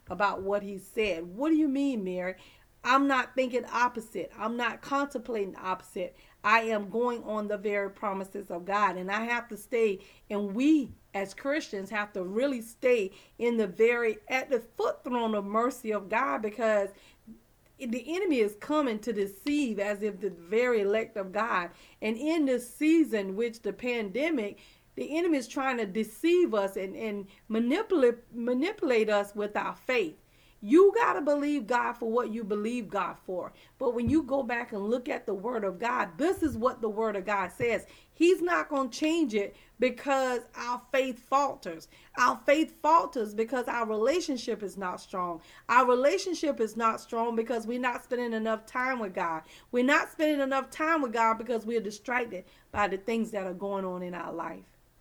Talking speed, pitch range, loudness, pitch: 185 wpm, 205-265 Hz, -29 LUFS, 230 Hz